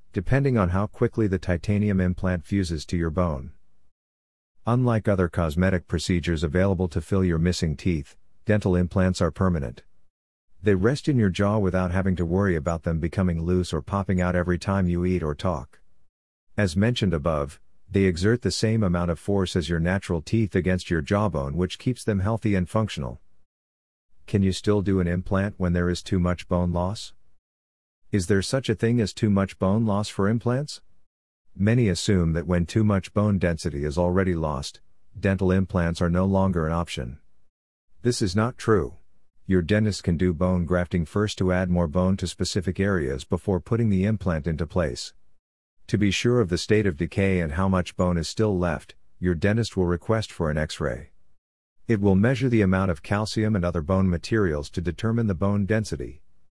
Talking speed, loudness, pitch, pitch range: 185 wpm, -24 LUFS, 95 Hz, 85-105 Hz